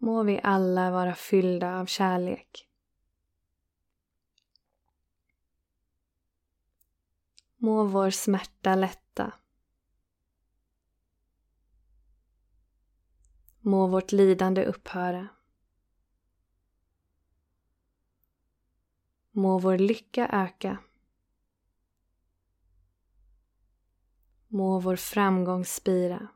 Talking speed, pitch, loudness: 50 wpm, 90 Hz, -27 LUFS